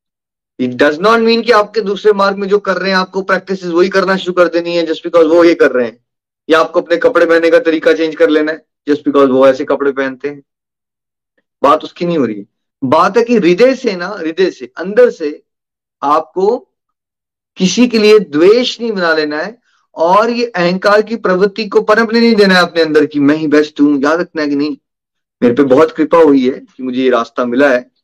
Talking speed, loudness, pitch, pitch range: 225 wpm, -11 LUFS, 170 Hz, 150-215 Hz